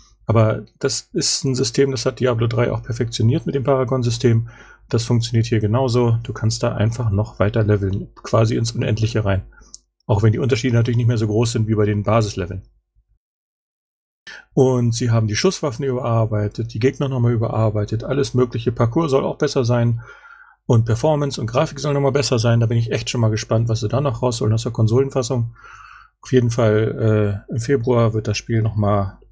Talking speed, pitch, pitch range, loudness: 190 wpm, 120 Hz, 110-130 Hz, -19 LUFS